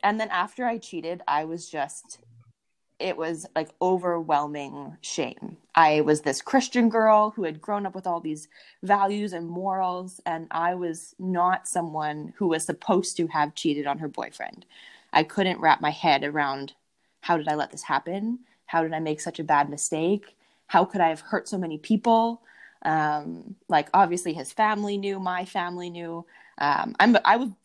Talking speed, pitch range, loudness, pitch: 175 wpm, 155-195 Hz, -25 LUFS, 170 Hz